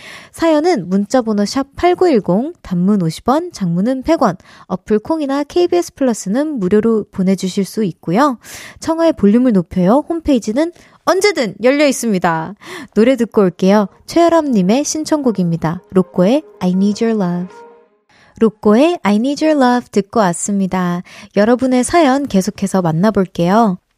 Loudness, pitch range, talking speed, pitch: -15 LUFS, 190-280 Hz, 330 characters per minute, 225 Hz